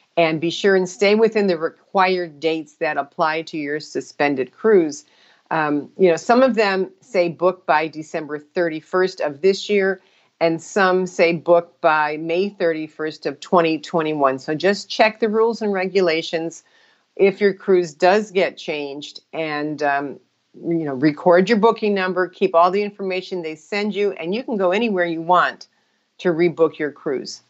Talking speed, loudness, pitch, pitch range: 170 wpm, -19 LUFS, 175 Hz, 155-195 Hz